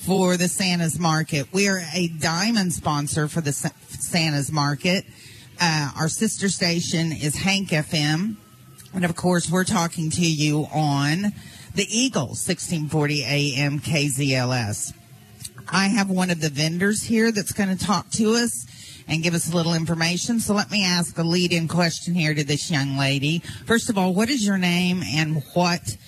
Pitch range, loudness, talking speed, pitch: 145-185 Hz, -22 LUFS, 175 wpm, 165 Hz